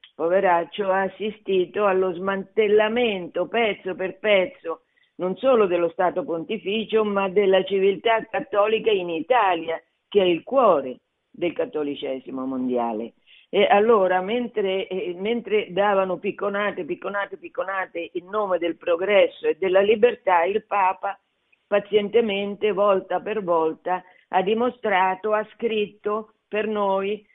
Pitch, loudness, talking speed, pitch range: 195 Hz, -23 LUFS, 120 wpm, 180-215 Hz